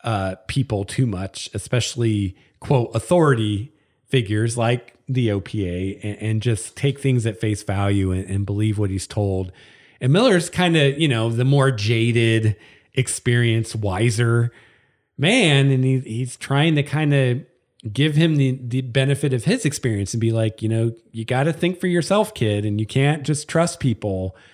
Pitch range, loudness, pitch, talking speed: 105-135 Hz, -21 LUFS, 120 Hz, 170 wpm